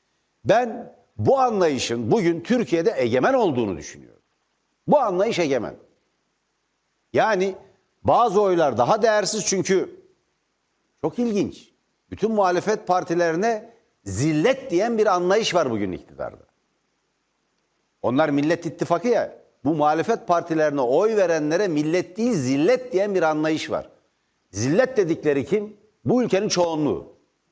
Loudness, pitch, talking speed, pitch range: -22 LUFS, 190 Hz, 110 wpm, 160-215 Hz